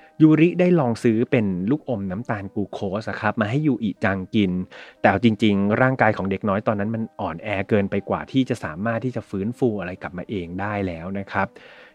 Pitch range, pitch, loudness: 100-120 Hz, 105 Hz, -22 LUFS